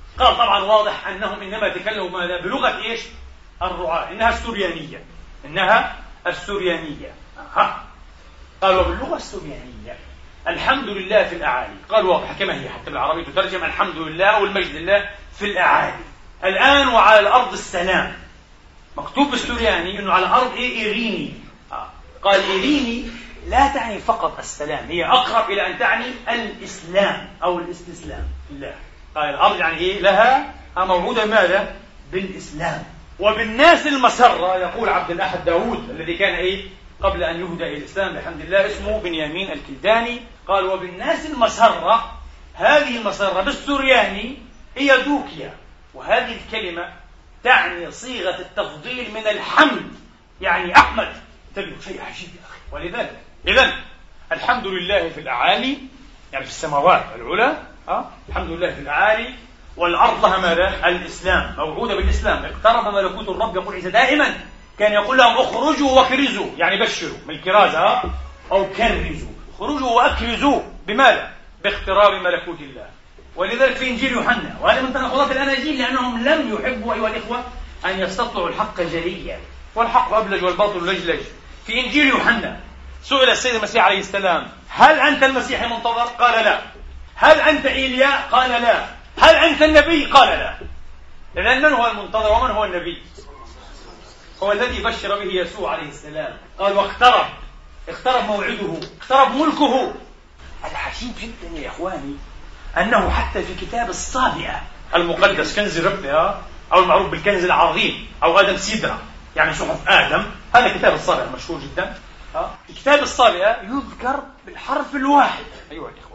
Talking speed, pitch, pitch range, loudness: 130 wpm, 215 Hz, 185-255 Hz, -18 LUFS